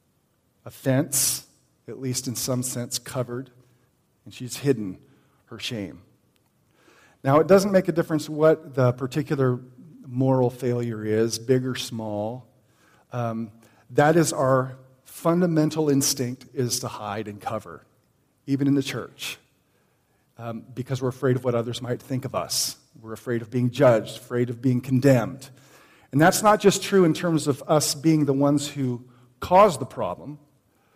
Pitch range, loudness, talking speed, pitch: 120-145 Hz, -23 LUFS, 150 wpm, 130 Hz